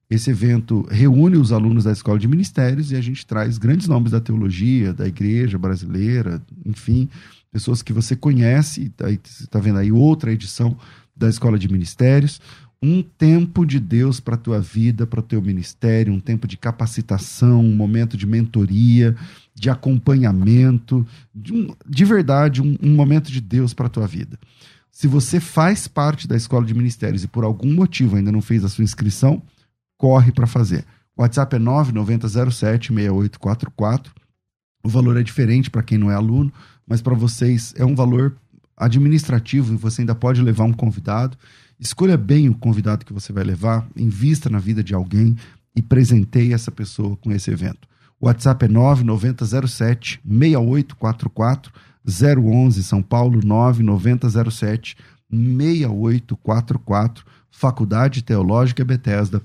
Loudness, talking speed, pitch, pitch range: -18 LUFS, 150 wpm, 120 Hz, 110-135 Hz